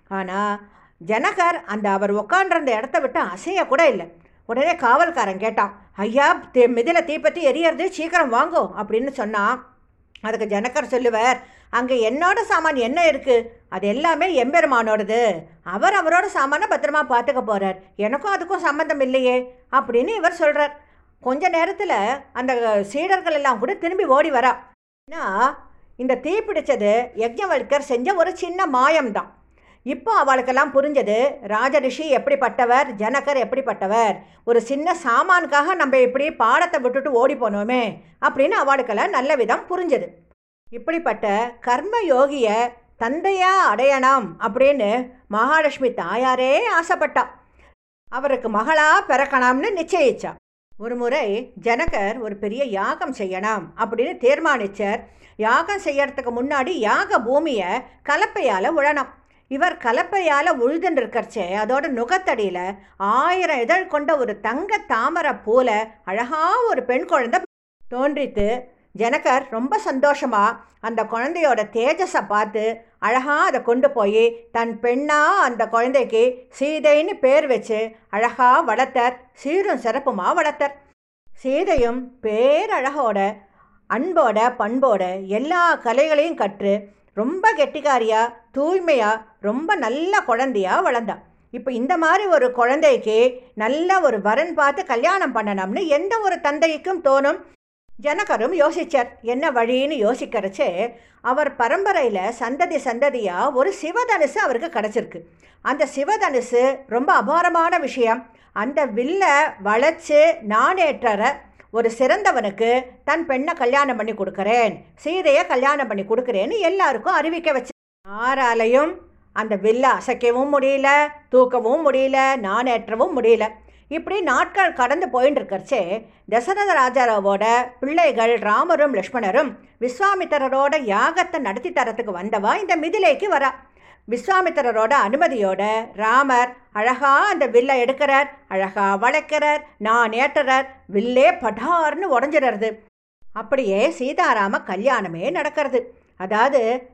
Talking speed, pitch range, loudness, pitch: 110 wpm, 230-310 Hz, -19 LUFS, 265 Hz